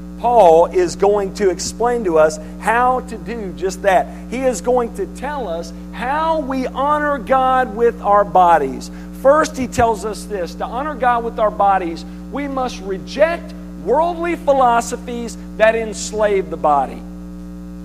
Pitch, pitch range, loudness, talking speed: 205 Hz, 165-245 Hz, -17 LUFS, 150 wpm